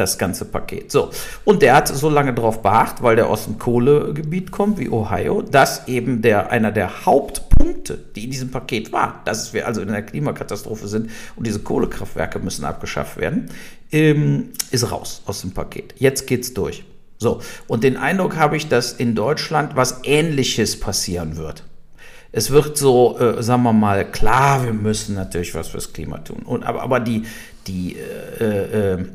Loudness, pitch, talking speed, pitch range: -19 LUFS, 120 Hz, 180 wpm, 105-145 Hz